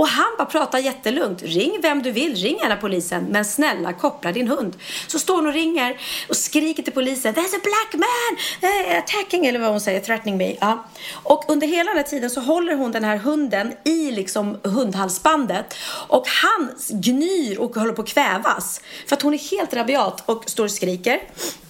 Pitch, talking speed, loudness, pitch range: 280 Hz, 195 wpm, -20 LUFS, 225-315 Hz